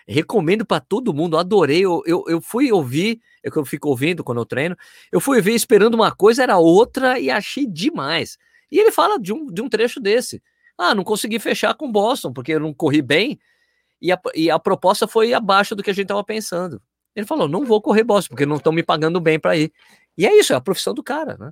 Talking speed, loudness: 230 wpm, -18 LUFS